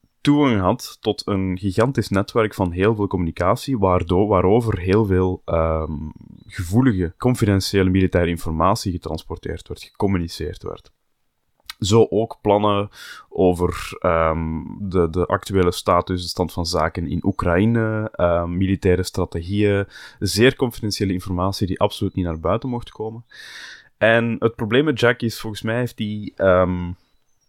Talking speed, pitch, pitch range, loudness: 135 wpm, 95 Hz, 90-110 Hz, -20 LUFS